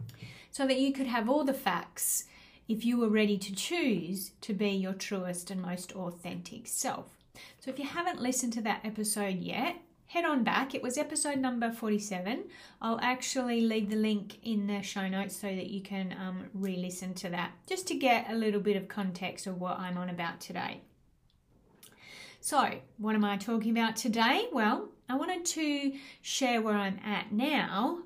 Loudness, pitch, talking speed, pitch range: -32 LUFS, 215 Hz, 185 wpm, 195-260 Hz